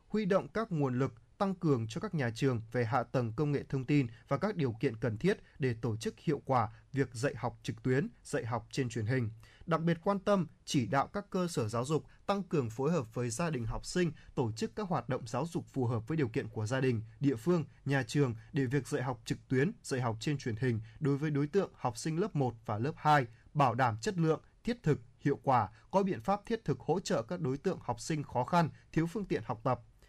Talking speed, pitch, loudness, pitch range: 255 wpm, 140 Hz, -34 LUFS, 125-160 Hz